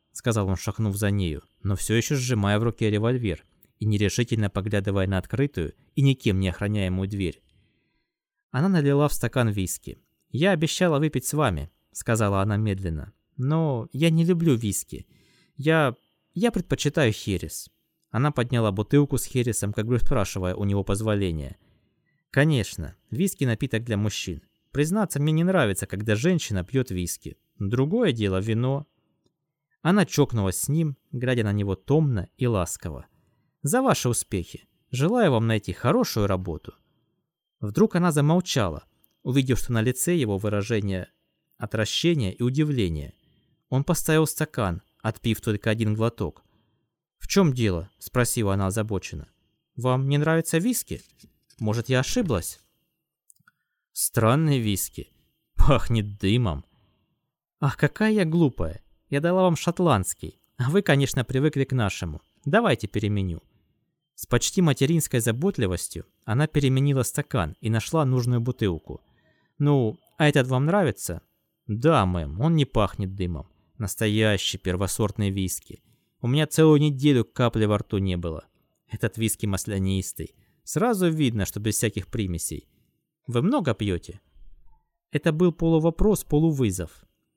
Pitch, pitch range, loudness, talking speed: 115 Hz, 100-145 Hz, -25 LUFS, 130 wpm